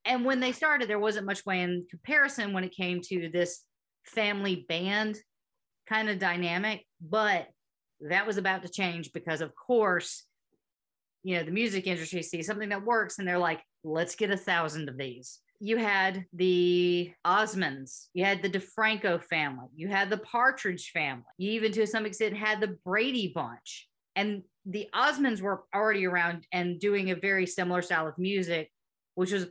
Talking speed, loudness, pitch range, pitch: 175 wpm, -29 LUFS, 175-215 Hz, 190 Hz